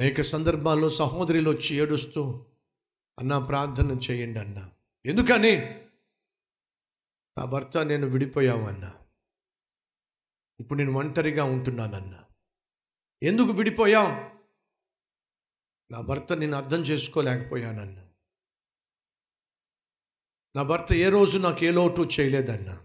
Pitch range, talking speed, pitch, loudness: 120-160 Hz, 85 wpm, 140 Hz, -25 LUFS